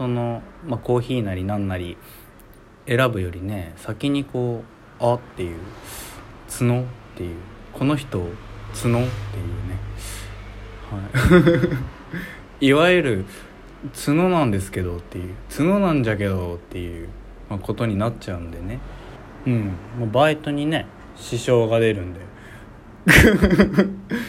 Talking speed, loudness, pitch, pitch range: 250 characters per minute, -21 LUFS, 110 Hz, 100-125 Hz